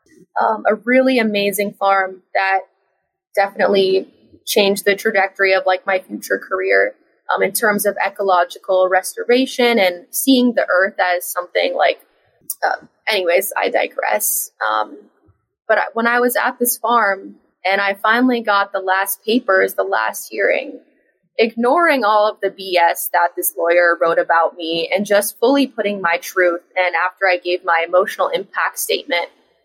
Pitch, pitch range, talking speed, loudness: 195 Hz, 180-215 Hz, 150 wpm, -17 LUFS